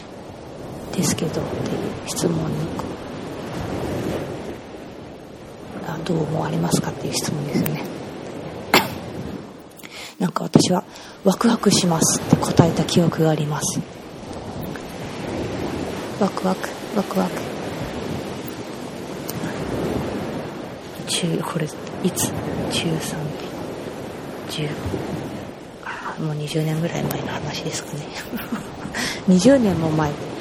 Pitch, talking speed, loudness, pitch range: 165 Hz, 155 characters per minute, -23 LUFS, 155-195 Hz